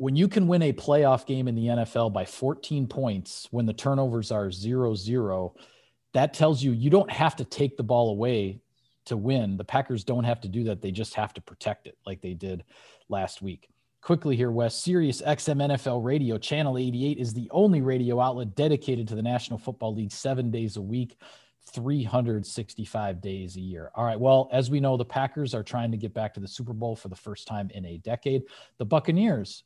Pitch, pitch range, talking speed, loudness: 120 Hz, 110-135 Hz, 210 wpm, -27 LUFS